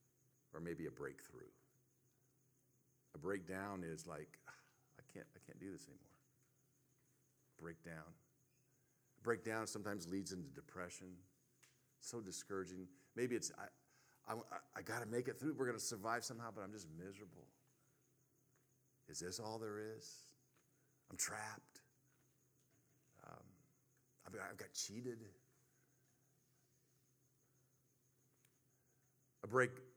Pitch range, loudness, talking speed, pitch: 110-130 Hz, -48 LUFS, 115 wpm, 130 Hz